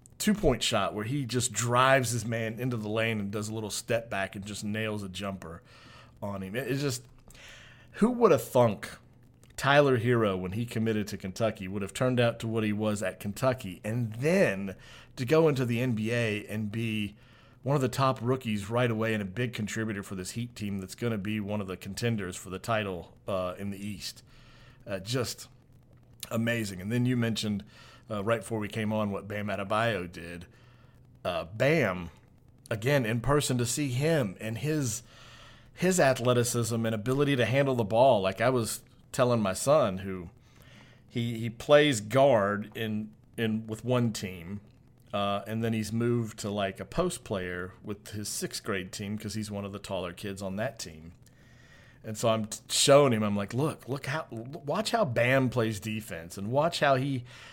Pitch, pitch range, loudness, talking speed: 115 Hz, 105-125 Hz, -29 LUFS, 190 wpm